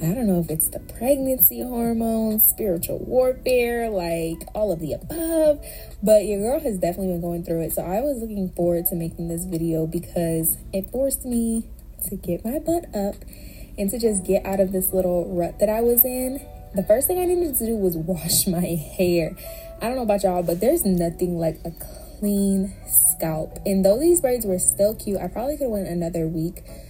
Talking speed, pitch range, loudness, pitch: 205 wpm, 170-230 Hz, -22 LUFS, 195 Hz